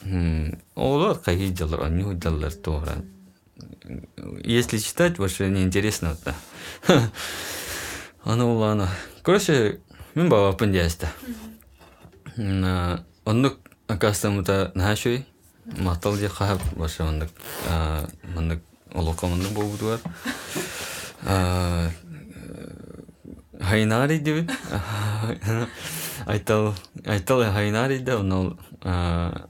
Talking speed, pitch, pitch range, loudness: 90 wpm, 95 Hz, 85-105 Hz, -25 LUFS